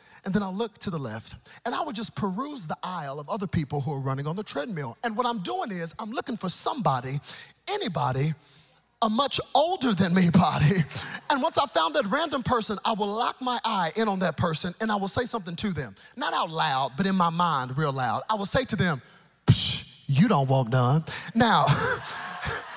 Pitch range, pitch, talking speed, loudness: 155-230 Hz, 190 Hz, 215 wpm, -26 LUFS